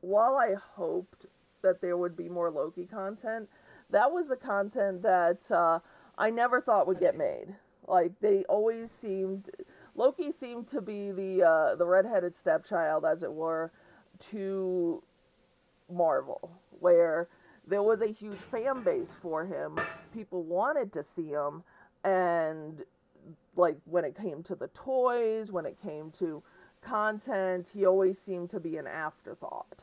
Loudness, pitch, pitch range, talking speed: -30 LUFS, 190 Hz, 175-215 Hz, 150 wpm